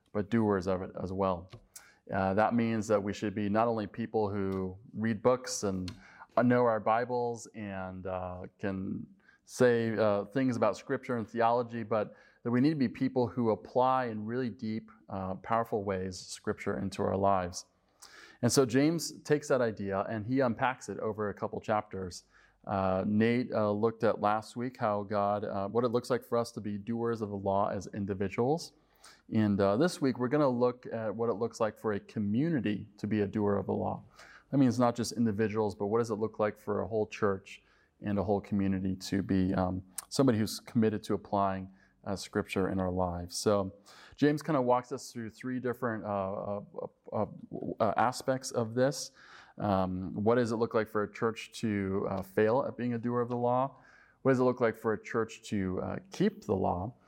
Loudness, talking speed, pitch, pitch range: -32 LUFS, 205 wpm, 110 Hz, 100-120 Hz